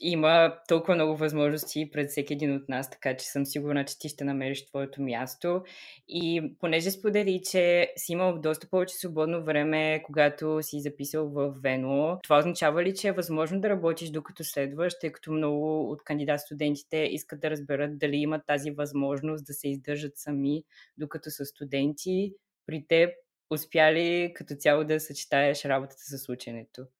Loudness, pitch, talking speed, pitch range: -28 LUFS, 155 Hz, 160 wpm, 145-165 Hz